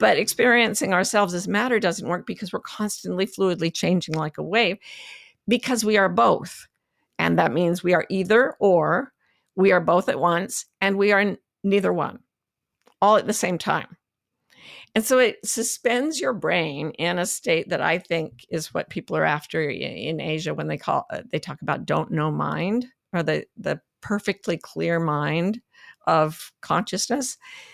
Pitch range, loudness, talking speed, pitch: 170-225 Hz, -23 LUFS, 170 wpm, 195 Hz